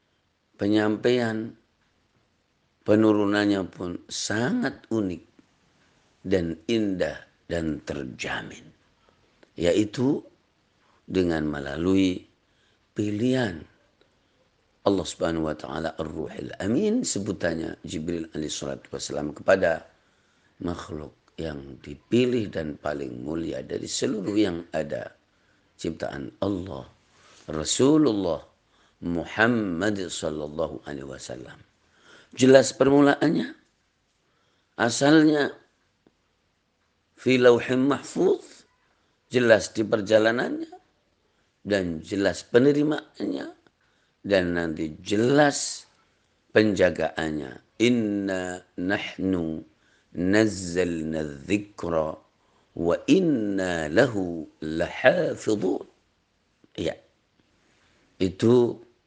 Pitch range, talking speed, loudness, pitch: 80-110 Hz, 70 wpm, -25 LUFS, 90 Hz